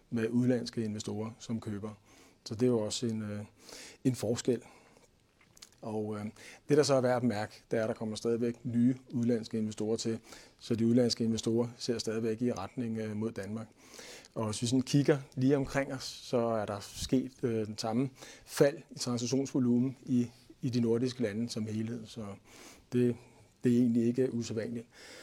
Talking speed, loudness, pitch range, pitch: 180 wpm, -33 LUFS, 110-125 Hz, 115 Hz